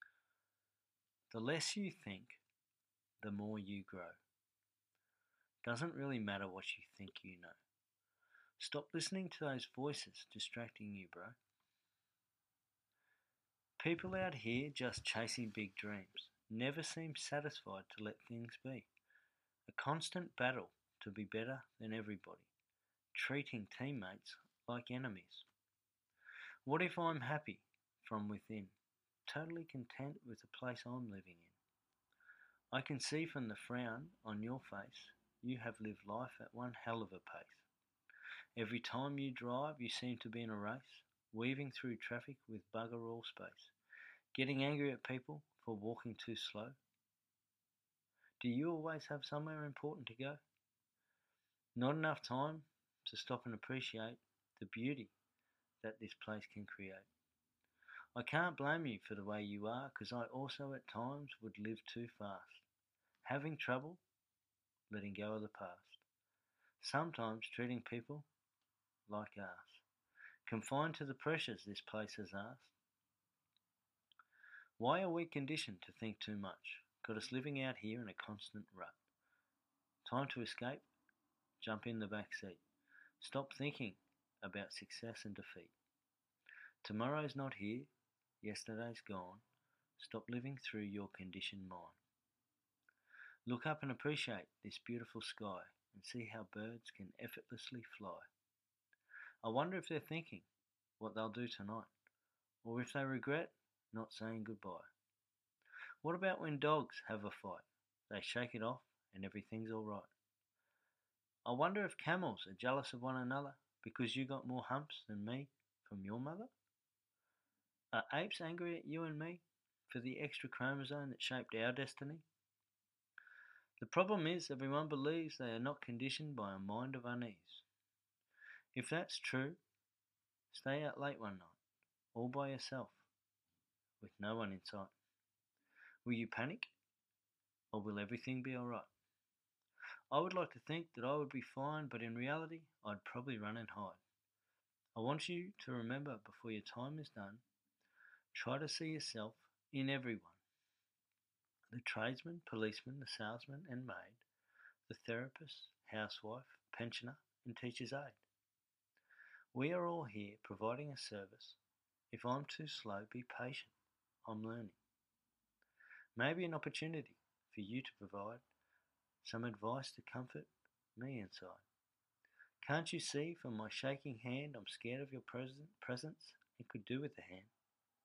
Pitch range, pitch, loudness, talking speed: 105-140 Hz, 120 Hz, -46 LUFS, 140 wpm